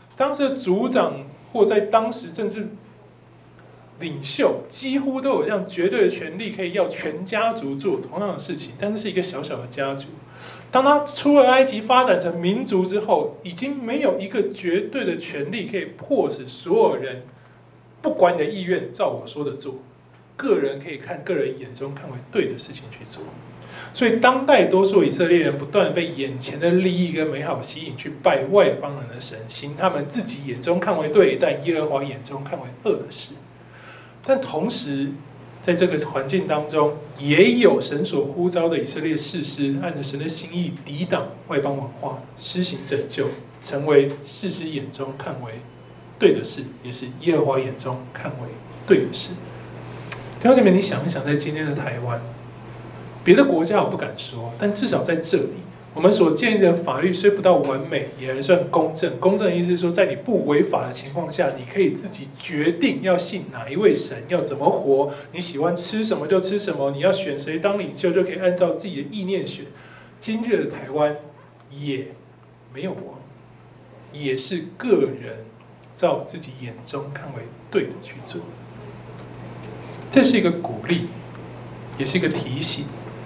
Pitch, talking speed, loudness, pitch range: 160 Hz, 260 characters per minute, -22 LUFS, 135-190 Hz